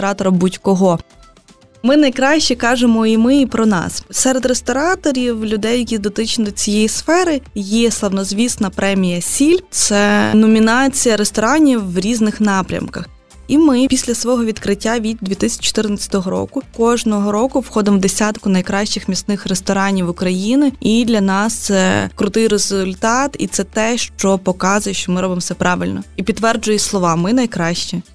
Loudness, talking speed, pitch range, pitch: -15 LUFS, 140 wpm, 195-240 Hz, 215 Hz